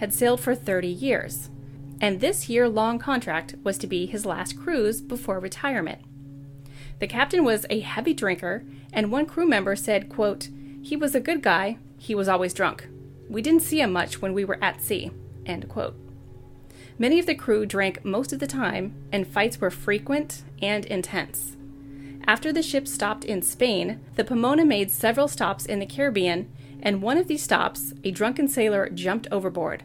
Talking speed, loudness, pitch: 180 wpm, -25 LUFS, 195 Hz